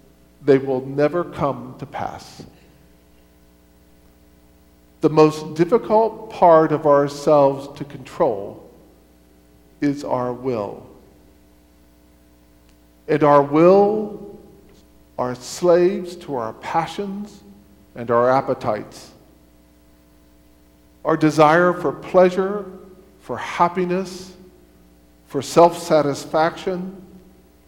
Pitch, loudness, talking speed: 140 Hz, -19 LUFS, 80 wpm